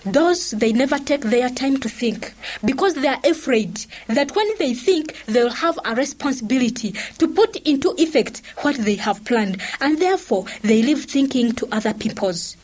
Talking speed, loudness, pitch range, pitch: 170 wpm, -20 LUFS, 220-295 Hz, 255 Hz